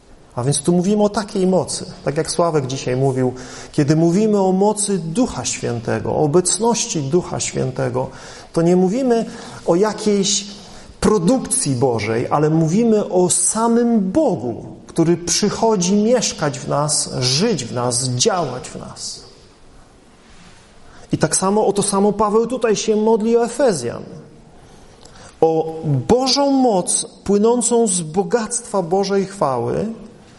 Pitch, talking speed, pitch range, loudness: 195 Hz, 130 wpm, 155-220 Hz, -17 LUFS